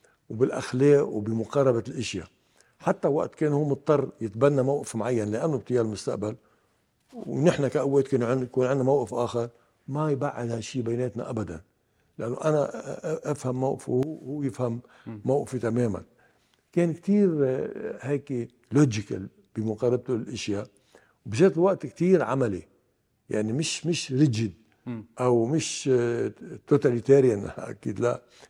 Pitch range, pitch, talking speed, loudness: 115-140 Hz, 125 Hz, 115 wpm, -26 LUFS